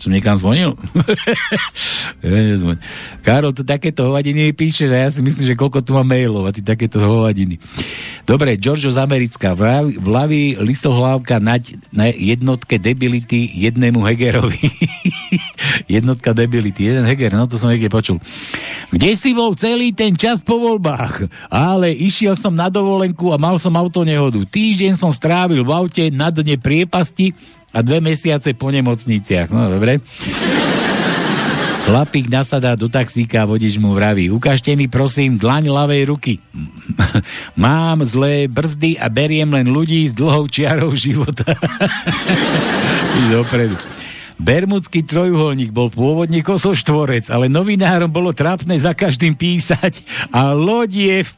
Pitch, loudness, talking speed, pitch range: 140 Hz, -15 LUFS, 140 wpm, 120-165 Hz